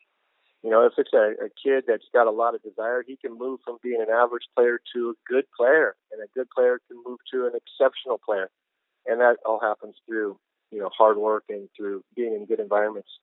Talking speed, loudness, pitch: 225 wpm, -24 LUFS, 360 Hz